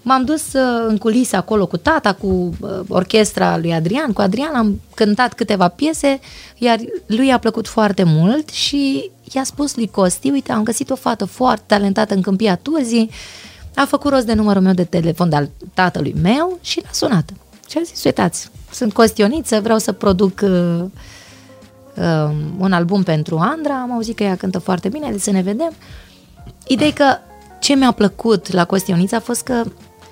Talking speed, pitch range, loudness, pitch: 175 wpm, 185-250 Hz, -17 LUFS, 215 Hz